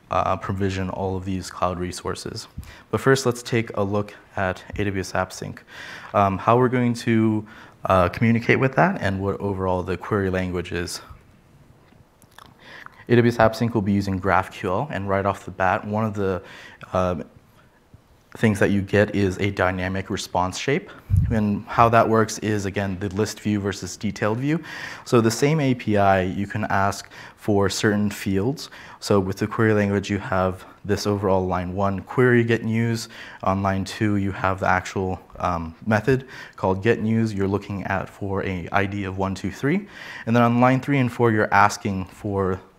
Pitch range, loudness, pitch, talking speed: 95-110 Hz, -22 LUFS, 100 Hz, 175 wpm